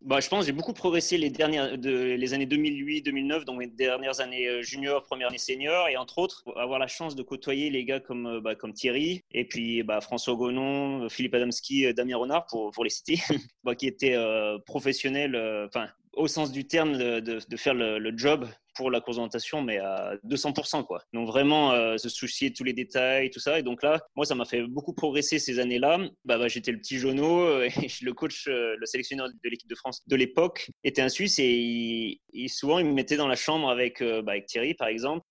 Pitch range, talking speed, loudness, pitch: 120-150 Hz, 215 wpm, -28 LUFS, 130 Hz